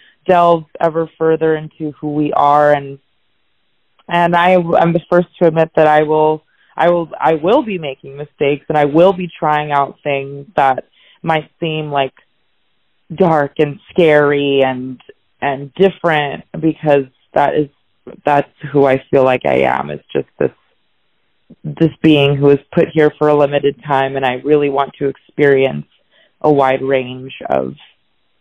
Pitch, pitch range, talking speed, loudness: 150 Hz, 140-160 Hz, 160 wpm, -14 LUFS